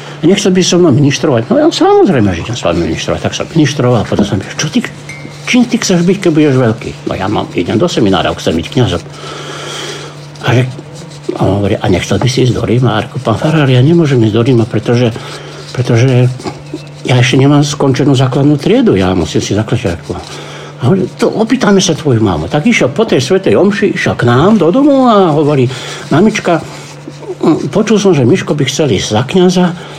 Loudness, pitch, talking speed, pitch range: -10 LUFS, 145 Hz, 205 wpm, 125-185 Hz